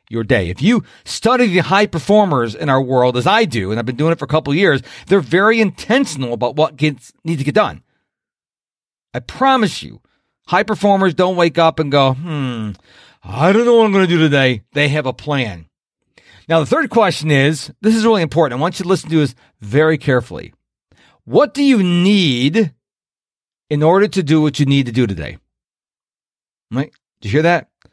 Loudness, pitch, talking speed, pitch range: -15 LUFS, 155 Hz, 205 wpm, 130-190 Hz